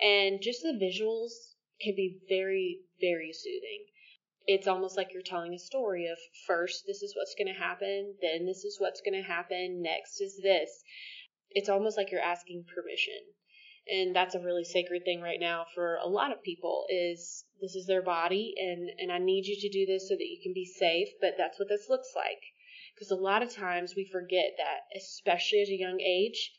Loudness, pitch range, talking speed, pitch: -32 LUFS, 180-260 Hz, 200 wpm, 195 Hz